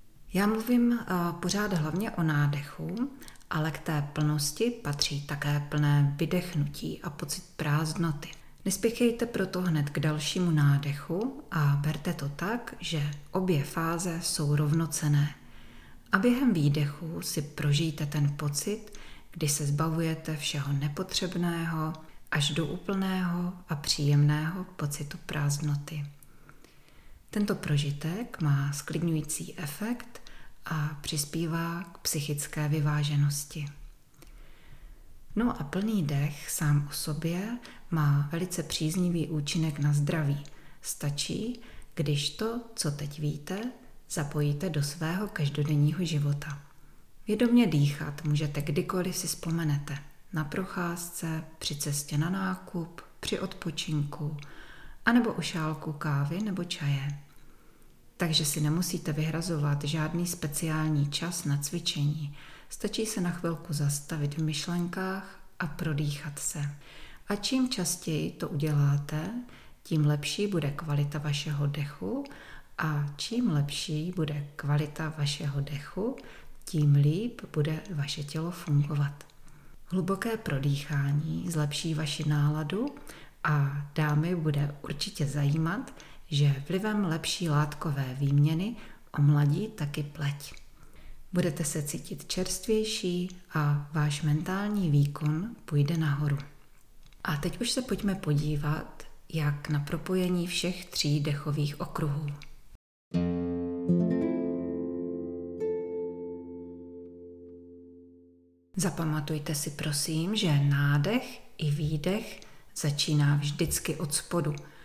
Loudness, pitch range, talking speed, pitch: -30 LUFS, 145-175 Hz, 105 wpm, 155 Hz